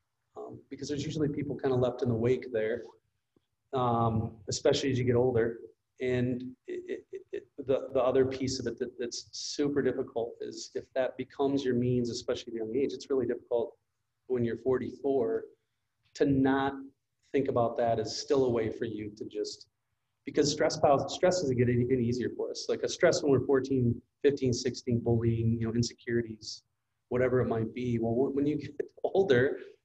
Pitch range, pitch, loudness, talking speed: 120-140 Hz, 130 Hz, -30 LUFS, 185 wpm